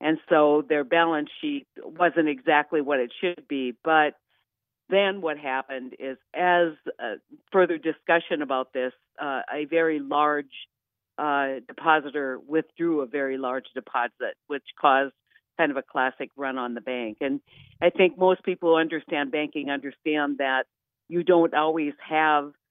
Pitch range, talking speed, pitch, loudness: 135-165 Hz, 150 wpm, 150 Hz, -25 LUFS